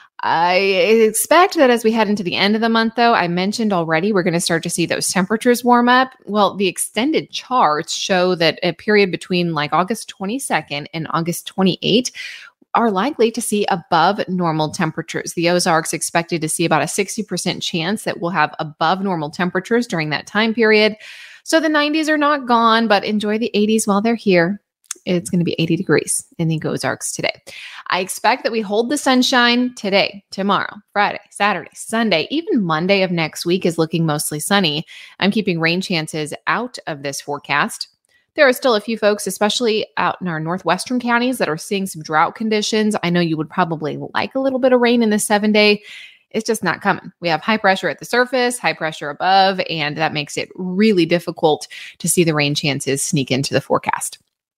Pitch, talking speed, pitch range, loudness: 195 Hz, 200 wpm, 165-225 Hz, -17 LUFS